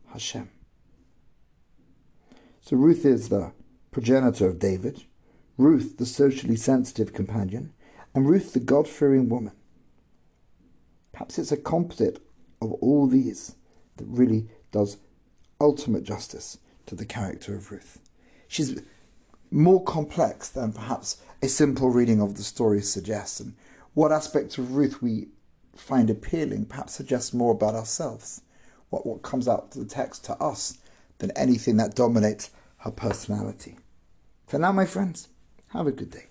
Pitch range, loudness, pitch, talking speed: 110-140 Hz, -25 LUFS, 125 Hz, 135 wpm